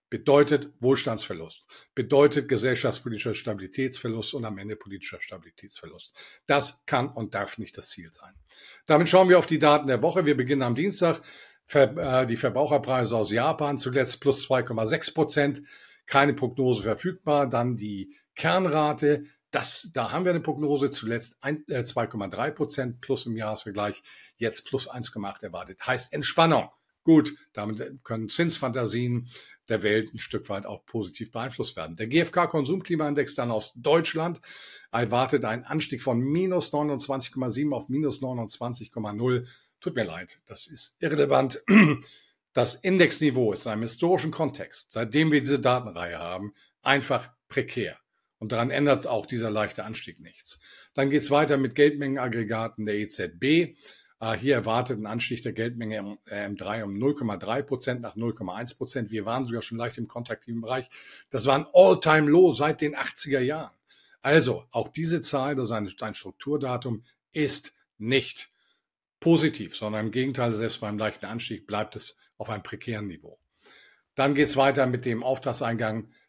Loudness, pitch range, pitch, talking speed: -26 LUFS, 110-145 Hz, 125 Hz, 150 wpm